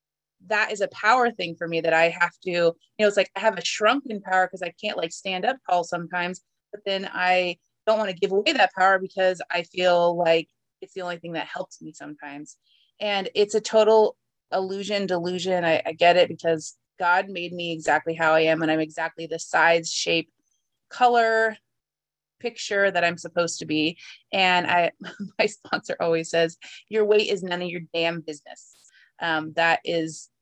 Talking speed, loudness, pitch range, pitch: 195 wpm, -23 LUFS, 165-195 Hz, 175 Hz